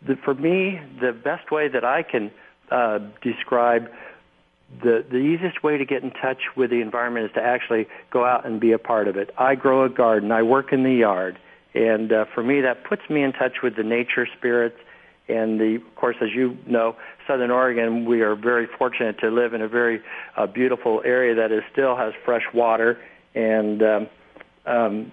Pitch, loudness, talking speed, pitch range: 120 Hz, -22 LUFS, 205 wpm, 115-130 Hz